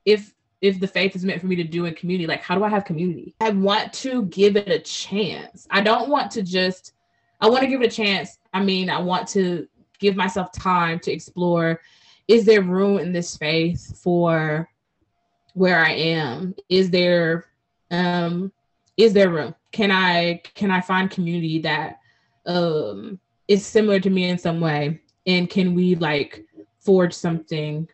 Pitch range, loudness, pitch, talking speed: 165-195 Hz, -21 LUFS, 180 Hz, 180 wpm